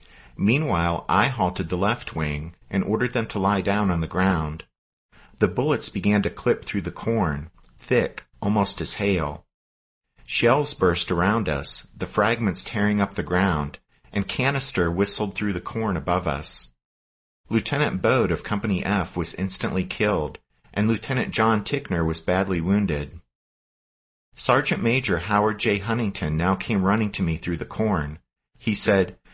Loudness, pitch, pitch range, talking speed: -23 LUFS, 95 Hz, 80-105 Hz, 155 wpm